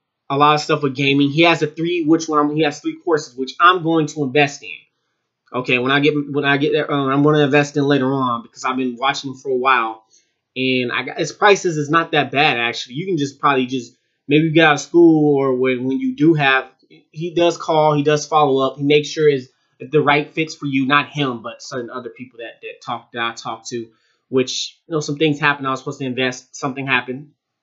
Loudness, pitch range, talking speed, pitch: -17 LUFS, 130-150 Hz, 250 wpm, 145 Hz